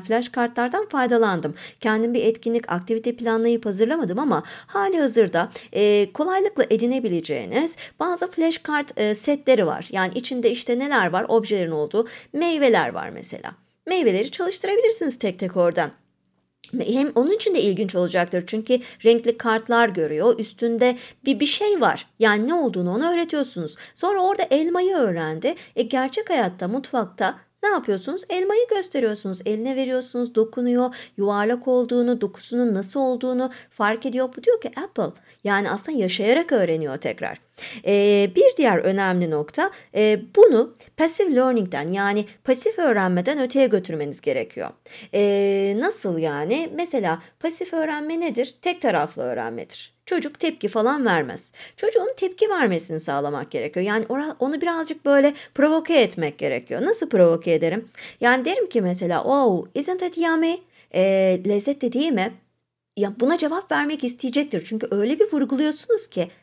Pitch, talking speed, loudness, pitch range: 245 Hz, 140 wpm, -22 LUFS, 205-310 Hz